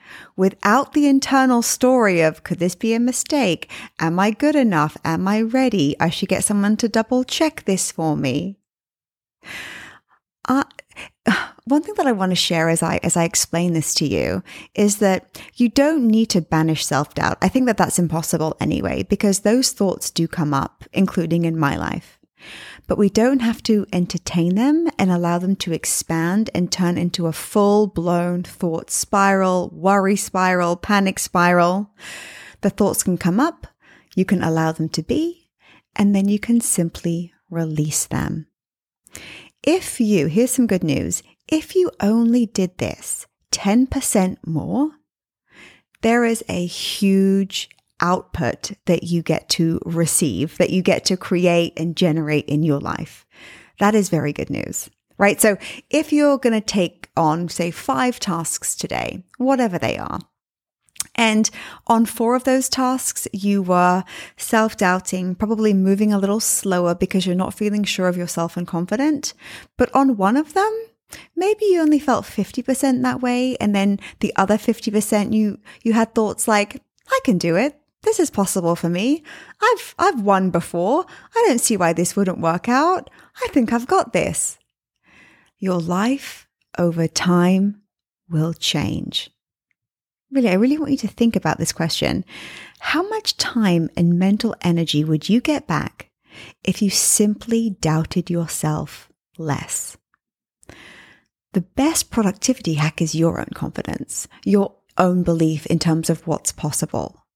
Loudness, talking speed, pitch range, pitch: -19 LUFS, 155 wpm, 170-240 Hz, 195 Hz